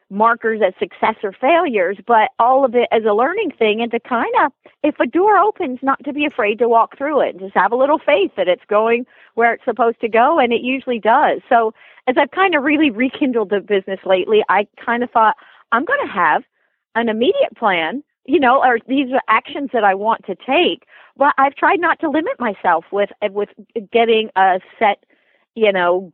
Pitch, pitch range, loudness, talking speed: 235 Hz, 215-280 Hz, -16 LUFS, 215 wpm